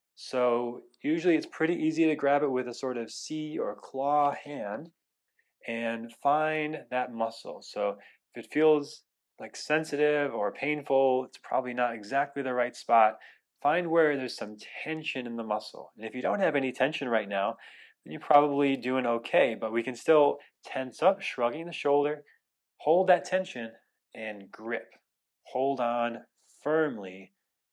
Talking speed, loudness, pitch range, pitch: 160 wpm, -29 LUFS, 120-150 Hz, 130 Hz